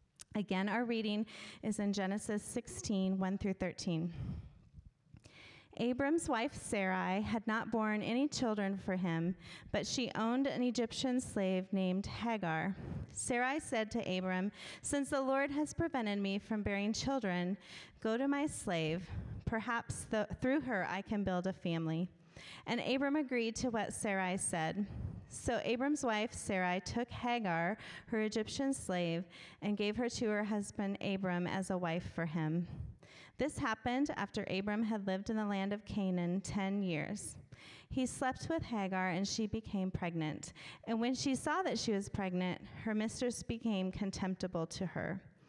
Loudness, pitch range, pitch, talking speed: -37 LUFS, 185-230 Hz, 205 Hz, 150 wpm